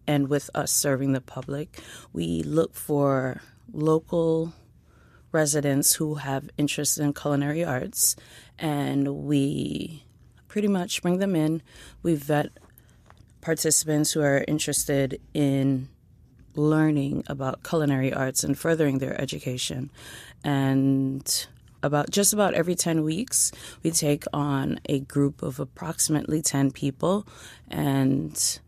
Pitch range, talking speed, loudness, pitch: 135-155 Hz, 115 wpm, -25 LUFS, 145 Hz